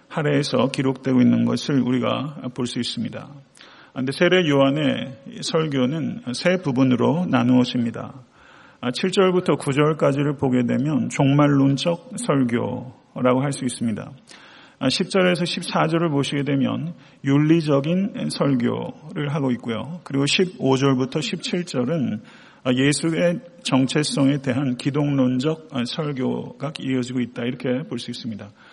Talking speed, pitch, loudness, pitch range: 260 characters per minute, 135 Hz, -21 LUFS, 125-155 Hz